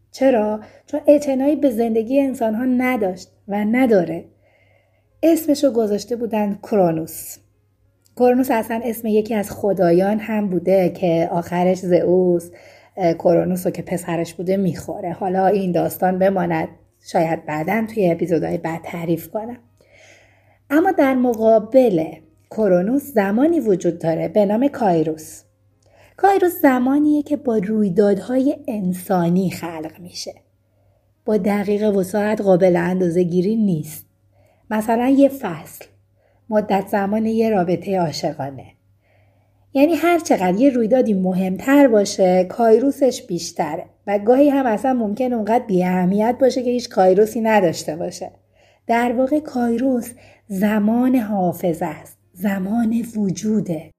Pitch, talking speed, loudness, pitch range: 200 Hz, 120 wpm, -18 LUFS, 170-235 Hz